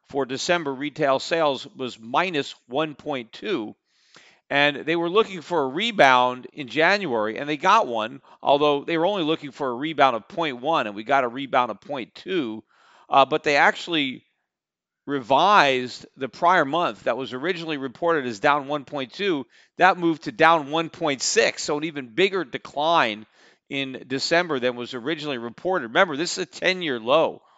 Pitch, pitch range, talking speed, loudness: 145 Hz, 130-160 Hz, 165 wpm, -22 LUFS